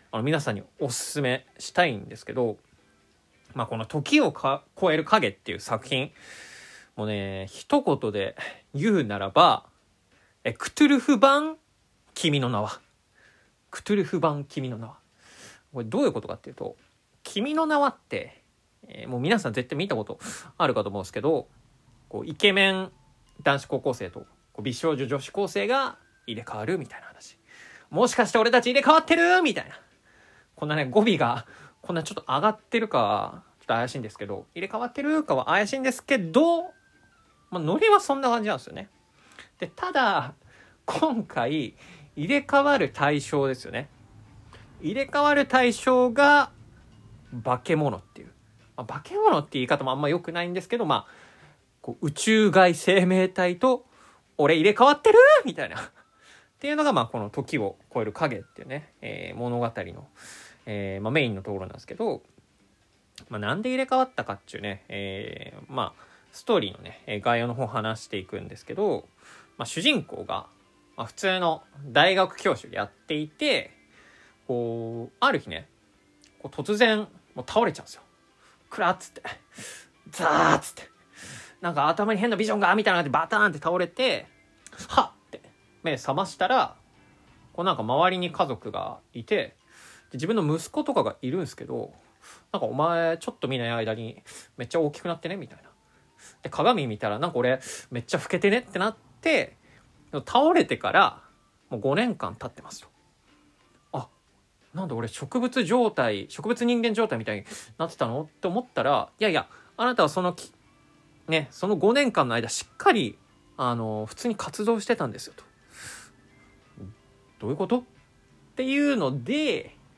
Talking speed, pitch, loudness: 320 characters per minute, 165 Hz, -25 LUFS